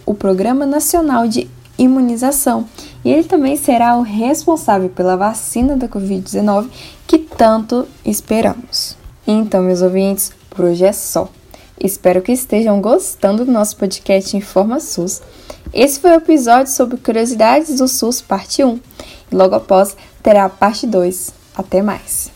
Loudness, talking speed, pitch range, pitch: -14 LUFS, 140 wpm, 195-260 Hz, 220 Hz